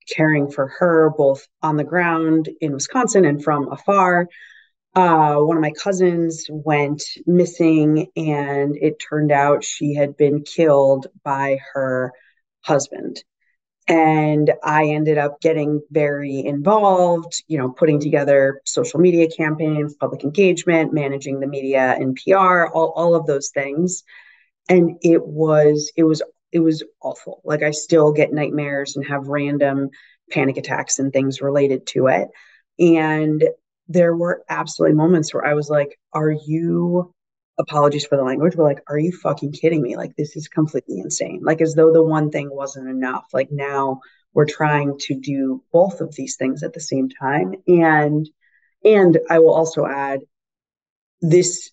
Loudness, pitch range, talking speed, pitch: -18 LUFS, 140-165 Hz, 155 wpm, 150 Hz